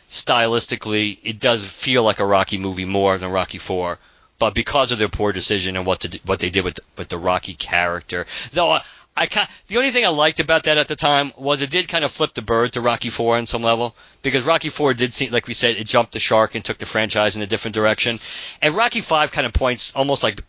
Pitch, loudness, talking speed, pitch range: 115 Hz, -19 LUFS, 250 wpm, 100-140 Hz